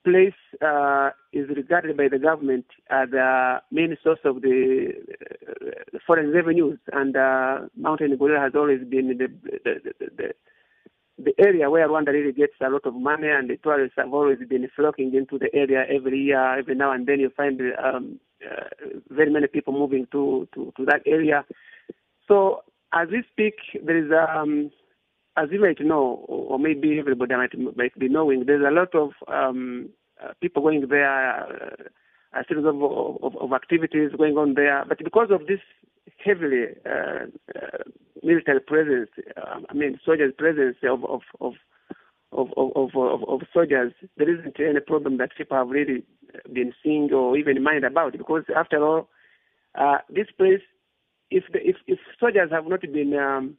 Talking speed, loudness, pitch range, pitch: 170 wpm, -22 LUFS, 135-180 Hz, 150 Hz